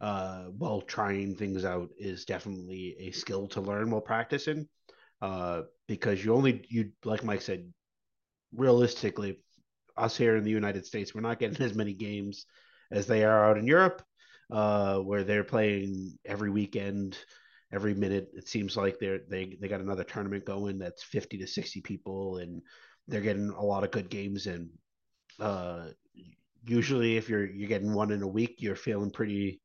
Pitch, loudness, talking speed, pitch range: 100 Hz, -31 LUFS, 170 wpm, 95-110 Hz